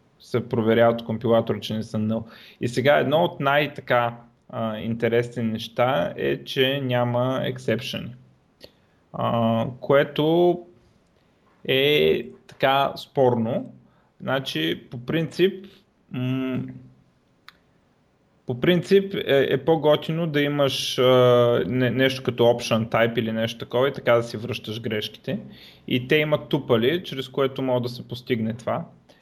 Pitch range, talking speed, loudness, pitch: 115-140 Hz, 125 wpm, -23 LUFS, 125 Hz